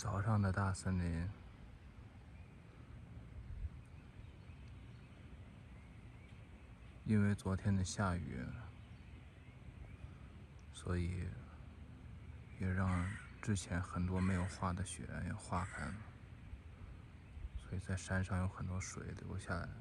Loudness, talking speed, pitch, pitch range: -41 LUFS, 125 characters per minute, 95 Hz, 90-105 Hz